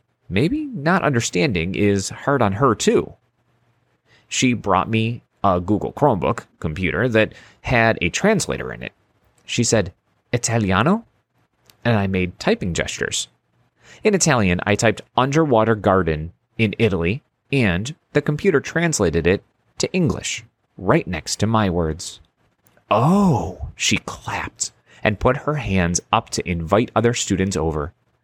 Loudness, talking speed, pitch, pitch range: -20 LUFS, 130 wpm, 110 Hz, 95-125 Hz